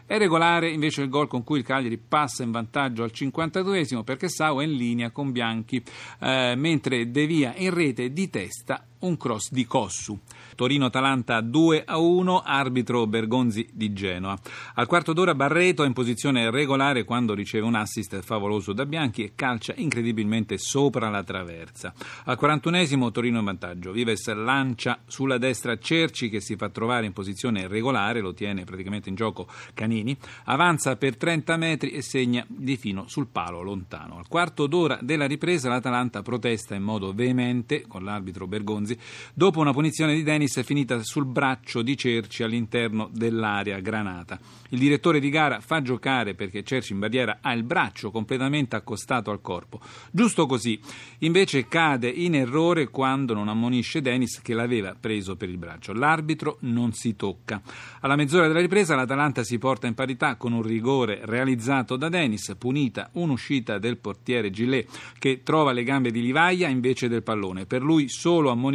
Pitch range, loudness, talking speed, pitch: 110-145 Hz, -25 LUFS, 170 wpm, 125 Hz